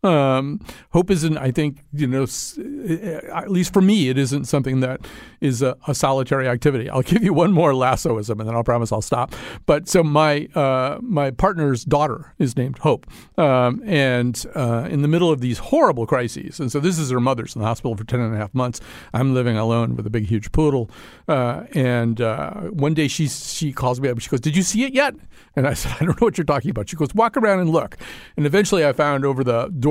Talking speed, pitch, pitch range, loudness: 235 wpm, 140 Hz, 125-160 Hz, -20 LUFS